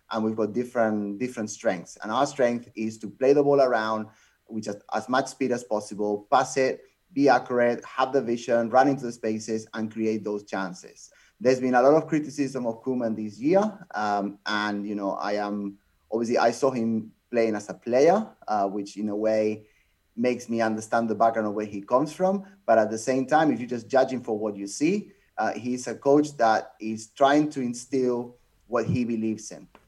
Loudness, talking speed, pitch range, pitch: -26 LUFS, 205 wpm, 105-130 Hz, 115 Hz